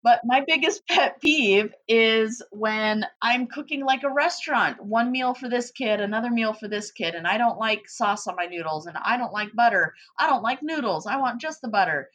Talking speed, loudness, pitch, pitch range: 215 wpm, -23 LUFS, 235 Hz, 210-265 Hz